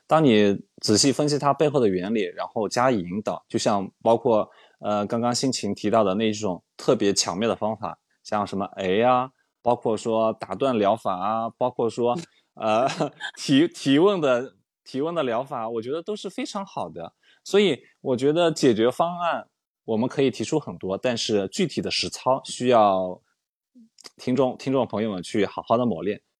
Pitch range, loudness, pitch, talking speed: 105-150 Hz, -24 LUFS, 120 Hz, 255 characters per minute